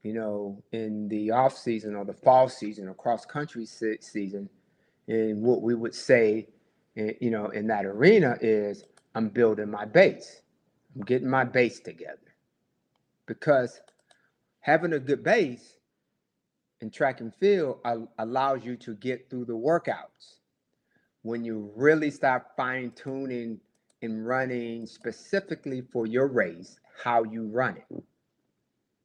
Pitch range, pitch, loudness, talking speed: 110-130 Hz, 115 Hz, -27 LUFS, 130 wpm